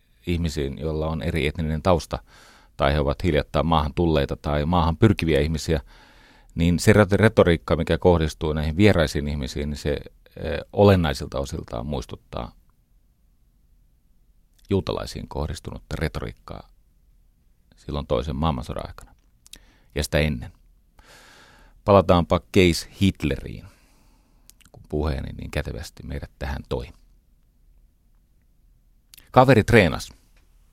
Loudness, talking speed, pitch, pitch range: -22 LUFS, 100 wpm, 80 Hz, 70-85 Hz